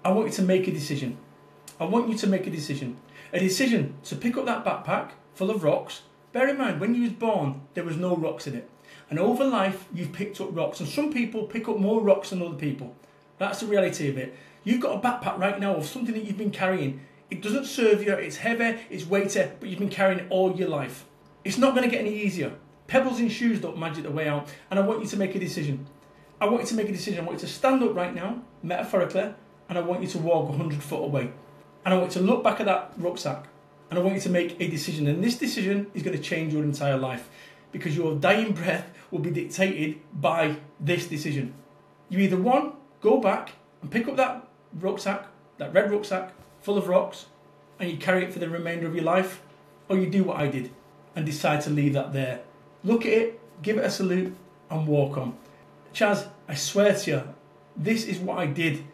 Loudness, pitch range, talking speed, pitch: -26 LUFS, 155-205 Hz, 235 wpm, 185 Hz